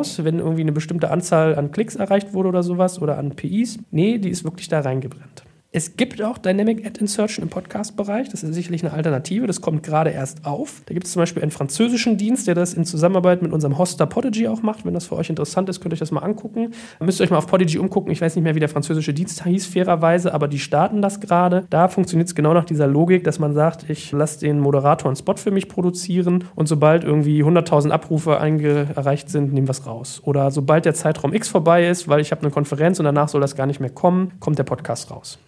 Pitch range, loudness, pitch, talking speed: 150-185 Hz, -20 LUFS, 165 Hz, 245 wpm